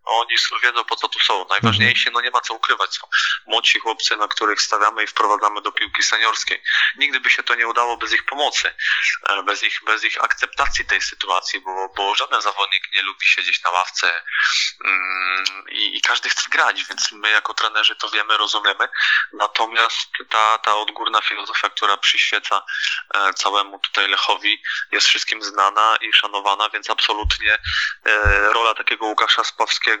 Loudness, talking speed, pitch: -18 LUFS, 160 wpm, 115 Hz